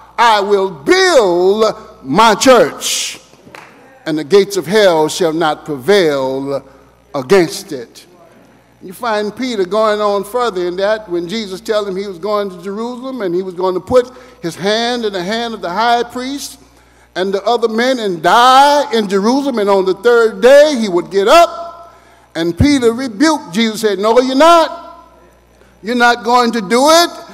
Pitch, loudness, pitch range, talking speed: 220 Hz, -12 LUFS, 190-250 Hz, 170 wpm